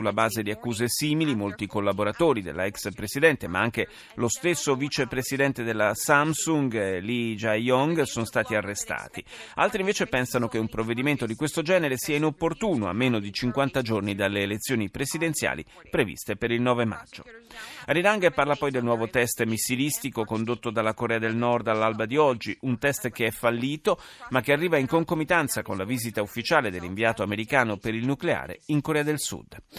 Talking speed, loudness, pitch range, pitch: 170 wpm, -26 LUFS, 110-145 Hz, 120 Hz